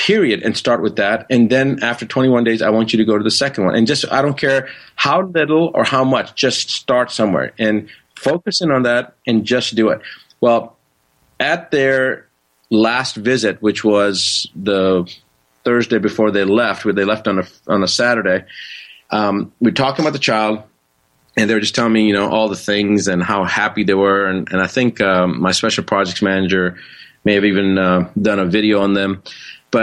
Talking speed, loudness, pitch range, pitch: 200 wpm, -16 LUFS, 100-120 Hz, 110 Hz